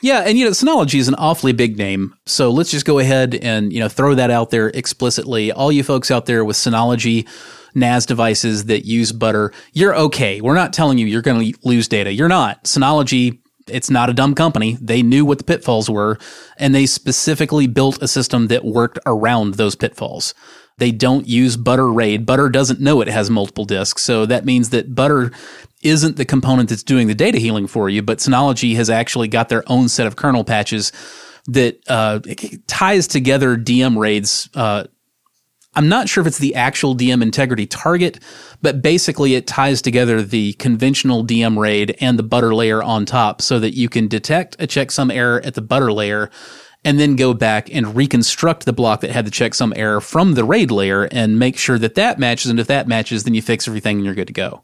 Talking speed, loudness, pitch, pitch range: 210 wpm, -15 LUFS, 120 Hz, 110-135 Hz